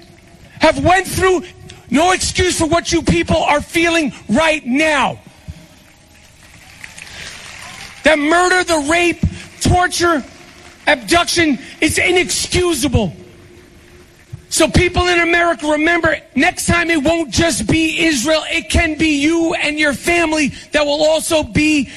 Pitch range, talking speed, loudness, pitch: 295-340 Hz, 120 wpm, -14 LUFS, 320 Hz